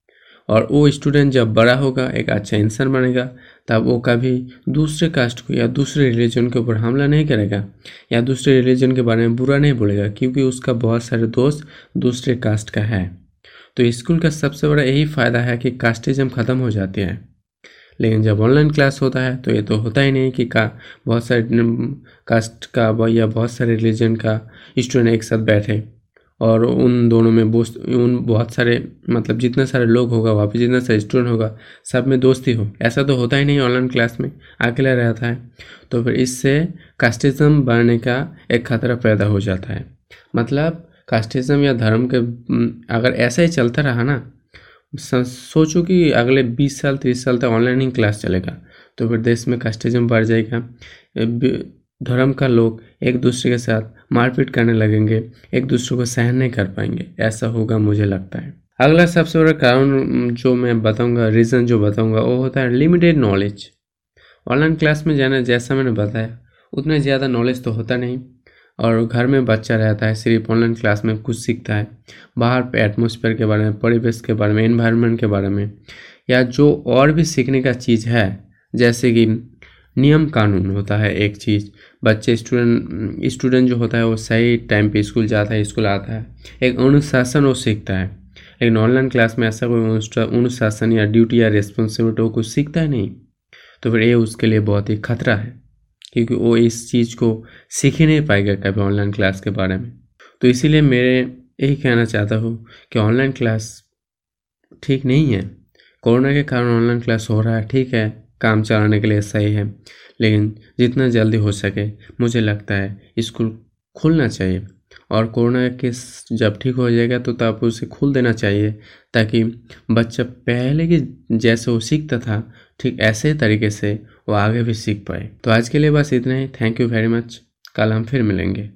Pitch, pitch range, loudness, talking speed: 120 Hz, 110-130 Hz, -17 LUFS, 185 wpm